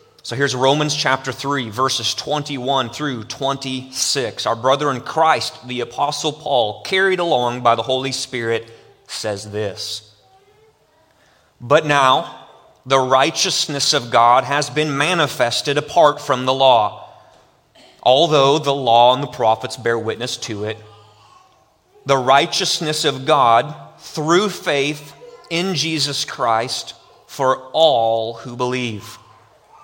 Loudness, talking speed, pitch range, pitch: -17 LUFS, 120 wpm, 120-150 Hz, 135 Hz